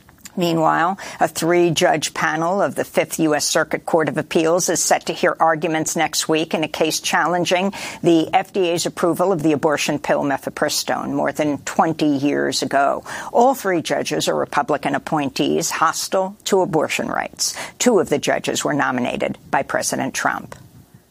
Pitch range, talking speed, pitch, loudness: 155-180 Hz, 155 wpm, 170 Hz, -19 LUFS